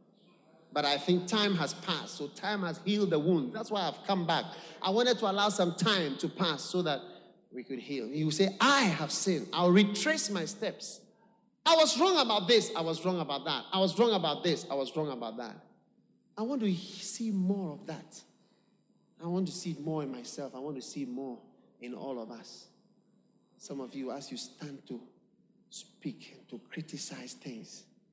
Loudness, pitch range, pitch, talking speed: -31 LUFS, 150-205 Hz, 180 Hz, 205 wpm